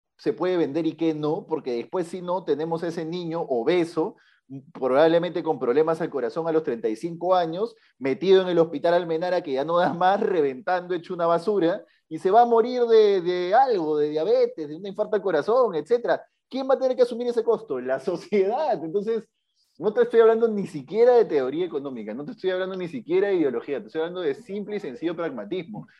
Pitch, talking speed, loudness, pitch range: 180 Hz, 205 wpm, -24 LUFS, 165-225 Hz